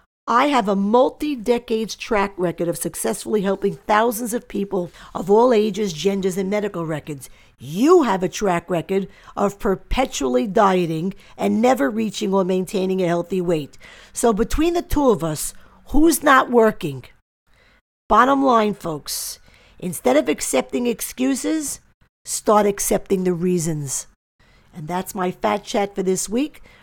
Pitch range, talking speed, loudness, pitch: 180-235 Hz, 145 wpm, -20 LUFS, 200 Hz